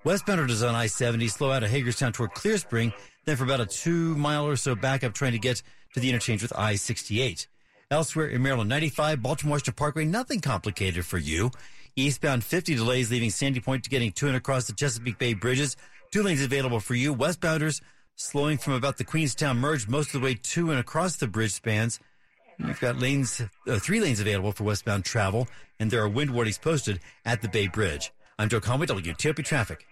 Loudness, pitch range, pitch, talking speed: -27 LUFS, 115-145 Hz, 125 Hz, 205 wpm